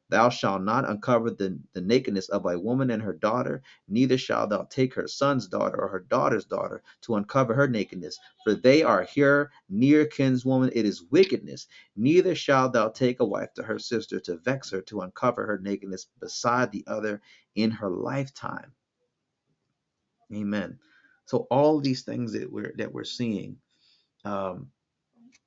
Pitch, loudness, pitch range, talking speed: 125 Hz, -26 LUFS, 105-140 Hz, 165 wpm